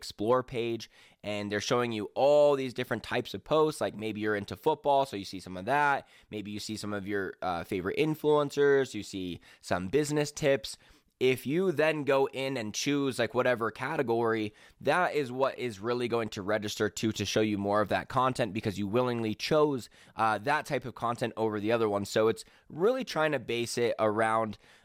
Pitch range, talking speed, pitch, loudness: 105-140 Hz, 205 wpm, 120 Hz, -30 LUFS